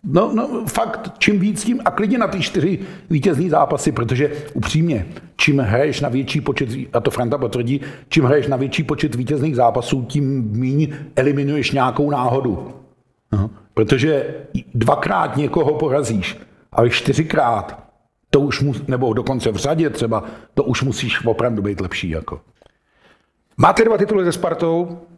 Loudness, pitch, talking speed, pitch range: -18 LUFS, 145 Hz, 155 wpm, 125-165 Hz